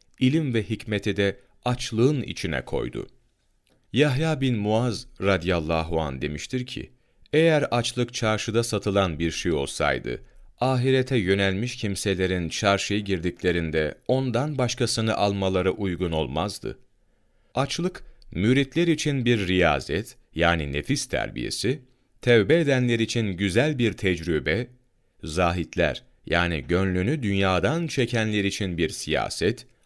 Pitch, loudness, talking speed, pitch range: 105 Hz, -25 LUFS, 105 wpm, 90-125 Hz